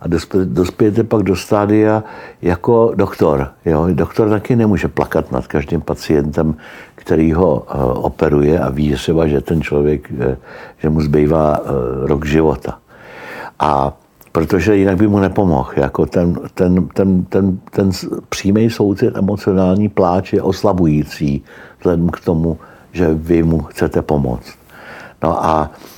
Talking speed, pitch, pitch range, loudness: 130 wpm, 85 Hz, 75-95 Hz, -15 LUFS